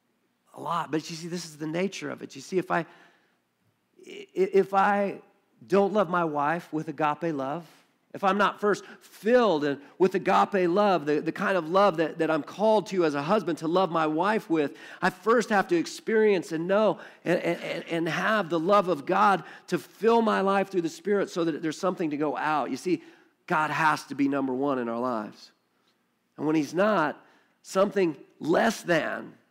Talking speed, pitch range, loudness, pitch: 195 wpm, 155-200 Hz, -26 LUFS, 180 Hz